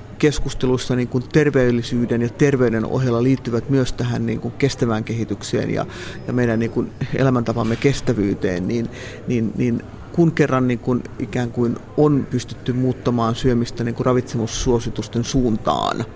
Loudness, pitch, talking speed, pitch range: -20 LUFS, 120 Hz, 125 wpm, 115-130 Hz